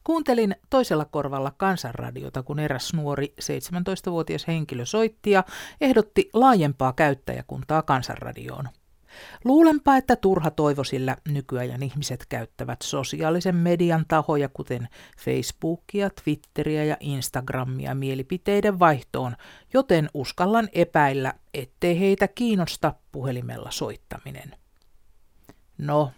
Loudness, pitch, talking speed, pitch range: -24 LUFS, 150 Hz, 95 wpm, 135-190 Hz